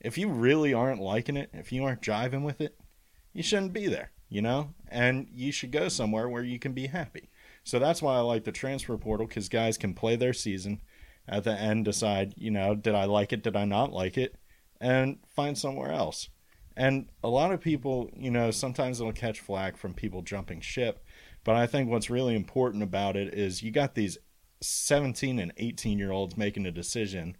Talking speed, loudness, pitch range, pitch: 210 wpm, -30 LUFS, 100-130 Hz, 115 Hz